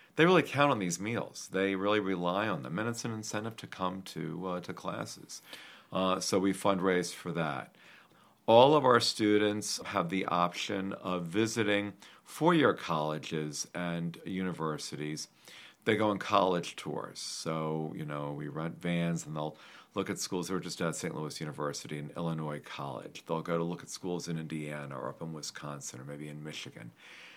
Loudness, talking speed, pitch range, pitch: -32 LUFS, 180 wpm, 75-95 Hz, 85 Hz